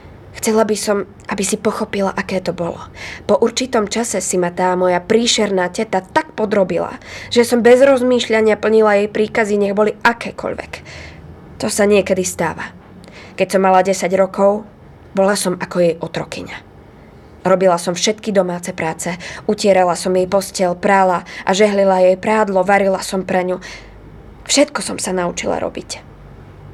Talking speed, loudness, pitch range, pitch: 150 wpm, -16 LUFS, 185-215 Hz, 195 Hz